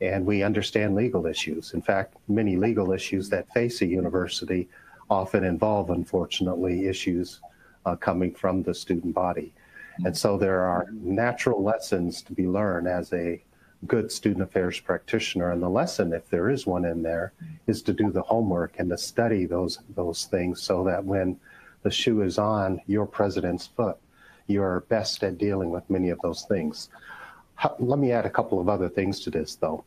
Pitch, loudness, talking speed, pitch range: 95 Hz, -26 LUFS, 180 wpm, 90-105 Hz